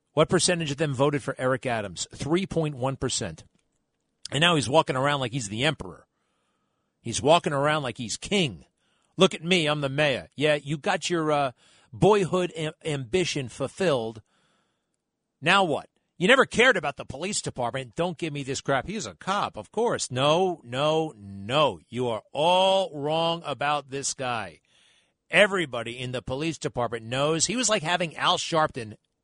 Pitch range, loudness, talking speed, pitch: 130-175 Hz, -25 LUFS, 165 wpm, 150 Hz